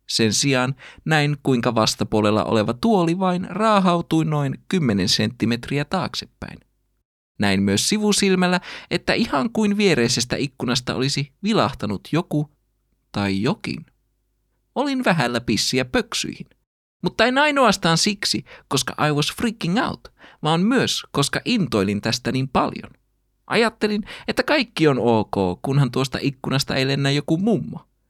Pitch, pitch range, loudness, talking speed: 145 Hz, 125-200 Hz, -21 LUFS, 125 wpm